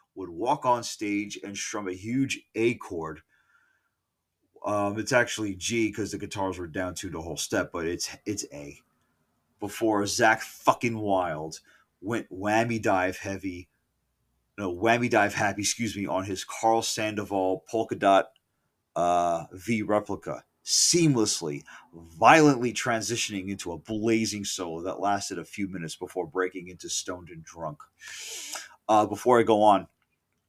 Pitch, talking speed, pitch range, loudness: 100 Hz, 145 wpm, 95-110 Hz, -27 LUFS